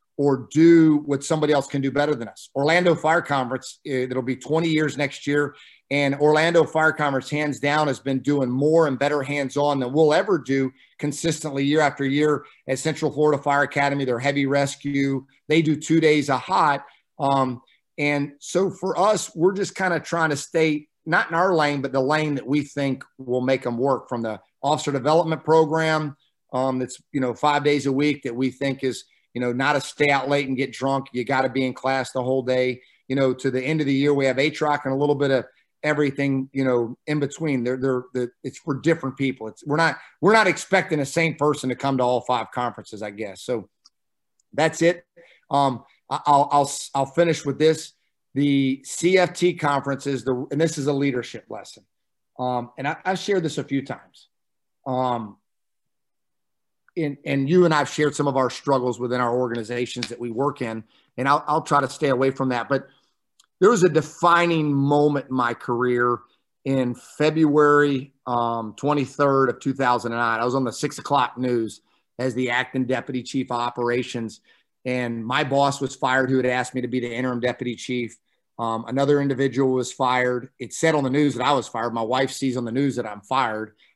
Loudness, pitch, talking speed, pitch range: -22 LUFS, 140 Hz, 205 wpm, 125-150 Hz